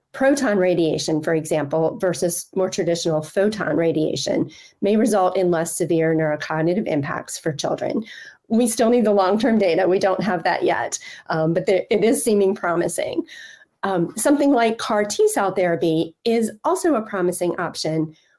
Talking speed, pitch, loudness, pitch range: 160 wpm, 185 Hz, -20 LUFS, 165-230 Hz